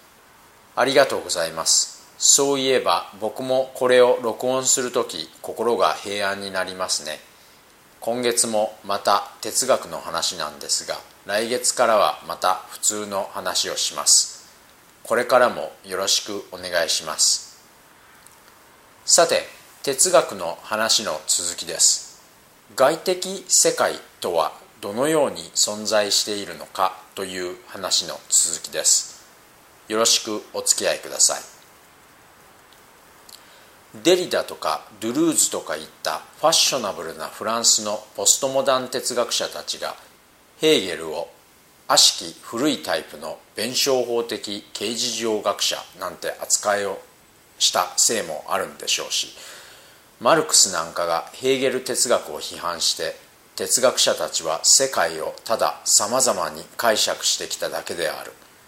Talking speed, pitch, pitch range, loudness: 270 characters per minute, 120 Hz, 105-135 Hz, -20 LUFS